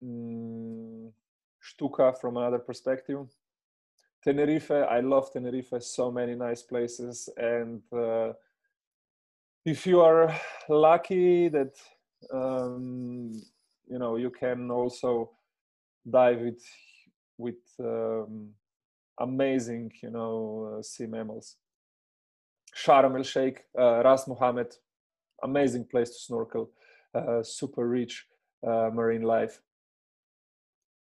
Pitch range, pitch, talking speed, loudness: 115-130 Hz, 120 Hz, 100 wpm, -28 LUFS